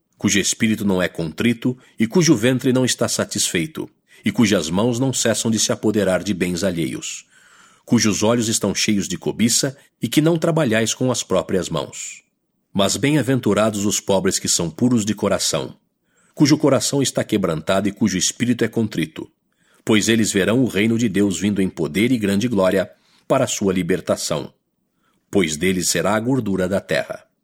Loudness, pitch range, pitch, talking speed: -19 LUFS, 100-125 Hz, 110 Hz, 170 wpm